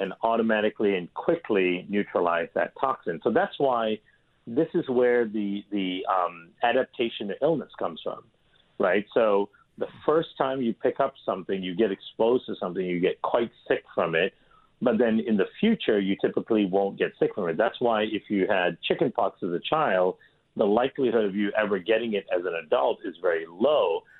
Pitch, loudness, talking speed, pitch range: 110 Hz, -26 LUFS, 185 wpm, 100-120 Hz